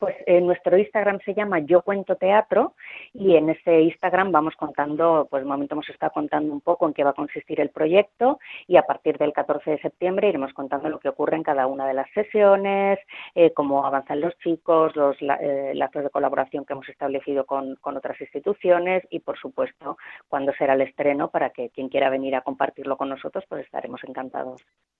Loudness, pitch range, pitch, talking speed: -23 LUFS, 140-180 Hz, 150 Hz, 200 wpm